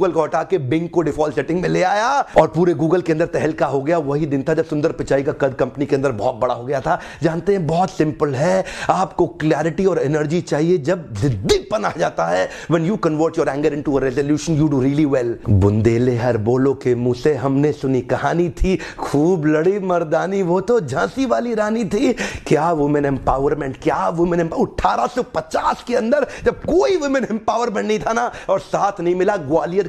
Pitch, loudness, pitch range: 160 Hz, -18 LUFS, 145-185 Hz